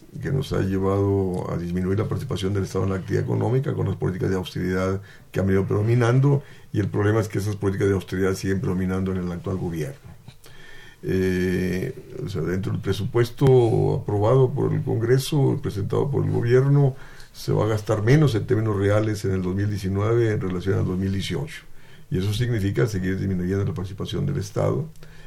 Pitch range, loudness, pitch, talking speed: 95-130 Hz, -23 LUFS, 105 Hz, 180 wpm